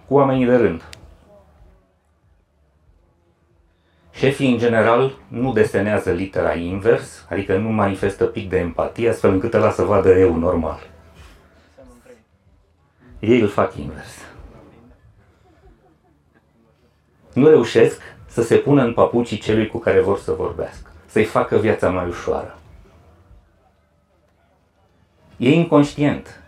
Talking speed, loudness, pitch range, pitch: 110 wpm, -18 LUFS, 85-115 Hz, 95 Hz